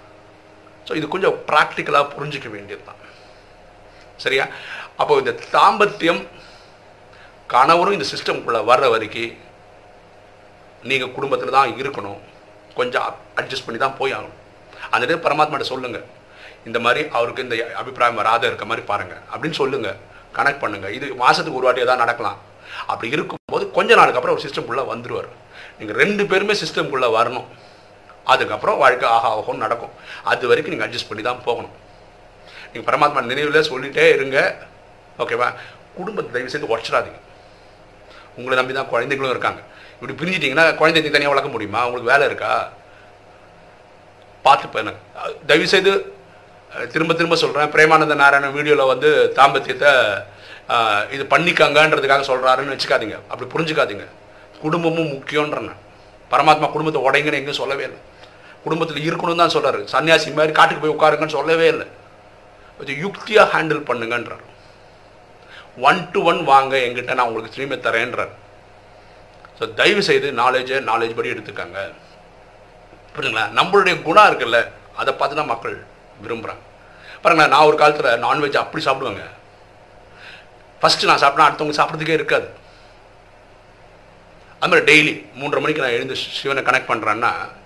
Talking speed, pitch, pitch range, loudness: 120 wpm, 130 Hz, 105-155 Hz, -17 LUFS